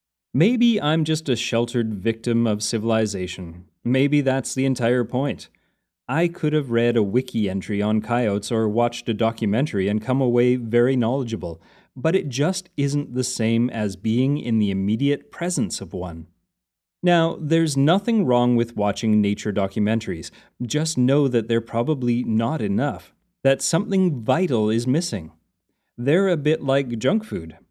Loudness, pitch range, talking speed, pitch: -22 LUFS, 110-145 Hz, 155 wpm, 120 Hz